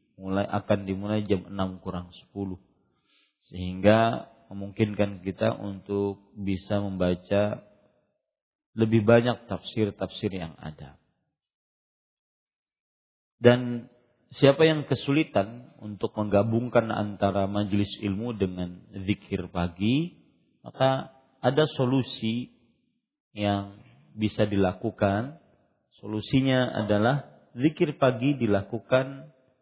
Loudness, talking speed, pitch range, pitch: -27 LUFS, 85 wpm, 100-125 Hz, 105 Hz